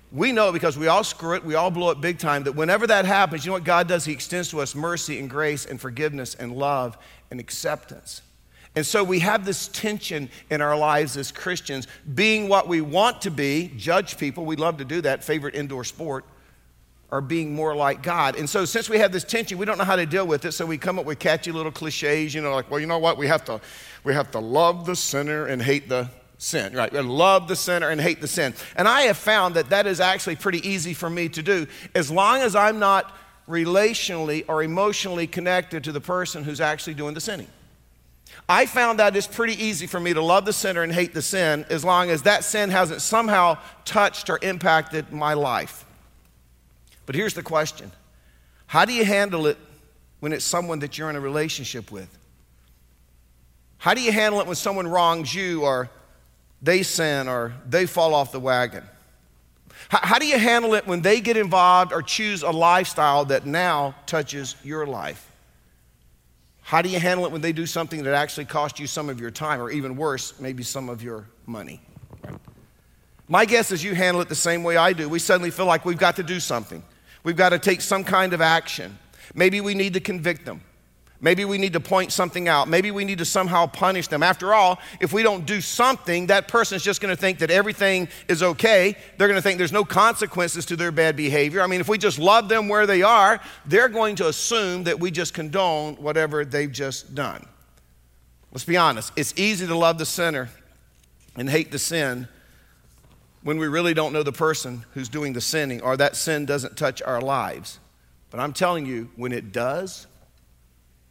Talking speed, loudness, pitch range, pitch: 210 wpm, -22 LUFS, 140-185 Hz, 165 Hz